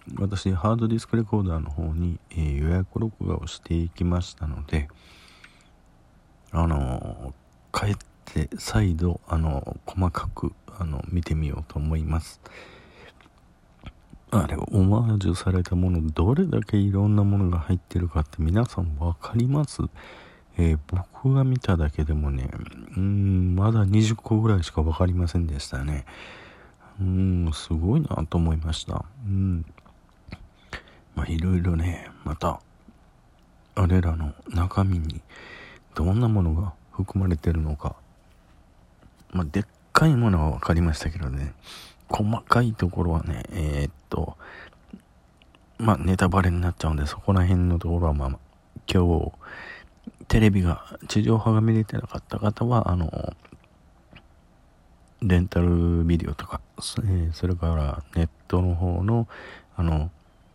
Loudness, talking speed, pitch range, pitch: -25 LUFS, 270 characters per minute, 80-95 Hz, 85 Hz